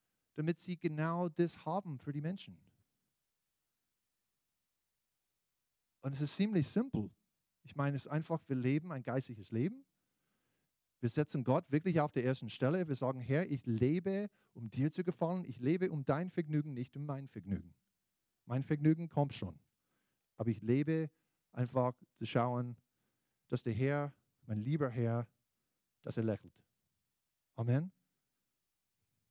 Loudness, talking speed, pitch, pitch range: -37 LUFS, 140 wpm, 140 Hz, 125-160 Hz